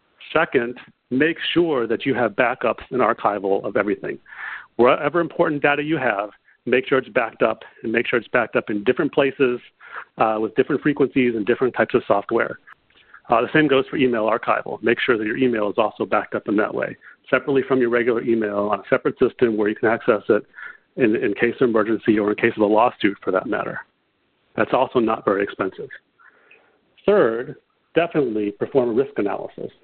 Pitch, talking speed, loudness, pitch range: 120 Hz, 195 wpm, -20 LUFS, 110-140 Hz